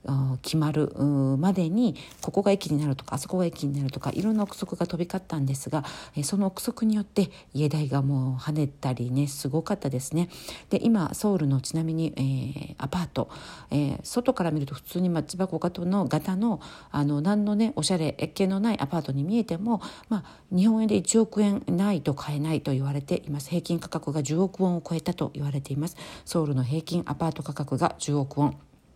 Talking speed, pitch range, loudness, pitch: 390 characters per minute, 145-190 Hz, -27 LUFS, 160 Hz